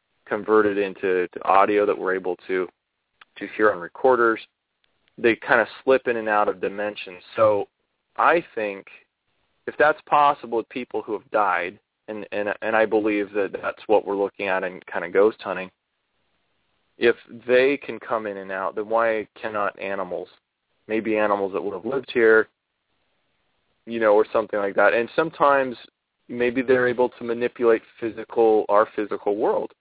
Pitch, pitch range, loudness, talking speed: 110 Hz, 105-125 Hz, -22 LUFS, 165 wpm